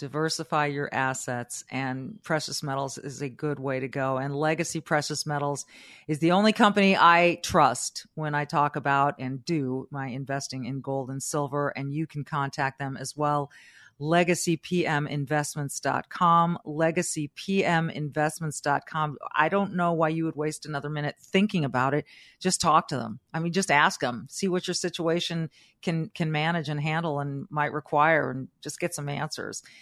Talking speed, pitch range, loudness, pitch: 165 wpm, 140-165 Hz, -27 LUFS, 150 Hz